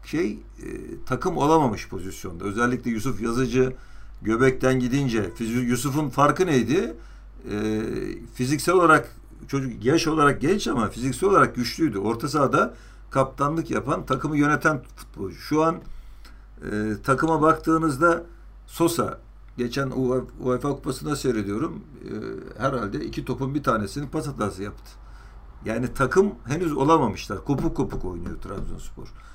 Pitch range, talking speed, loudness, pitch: 115-150 Hz, 125 wpm, -24 LUFS, 130 Hz